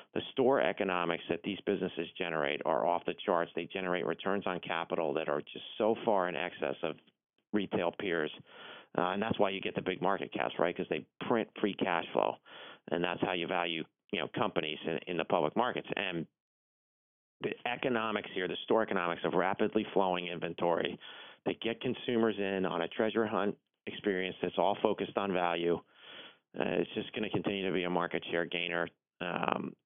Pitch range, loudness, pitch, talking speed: 85-110 Hz, -34 LUFS, 95 Hz, 190 wpm